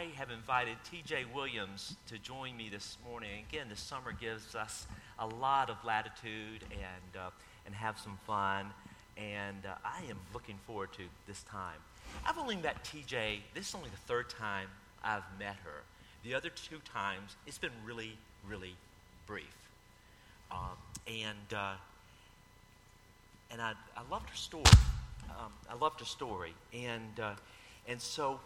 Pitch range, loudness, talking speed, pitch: 100-115 Hz, -38 LUFS, 155 wpm, 105 Hz